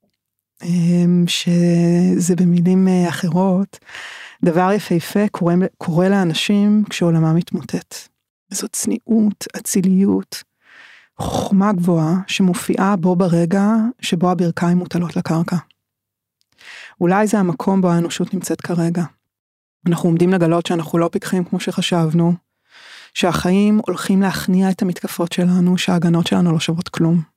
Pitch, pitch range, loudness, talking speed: 180 Hz, 170-195 Hz, -17 LUFS, 105 wpm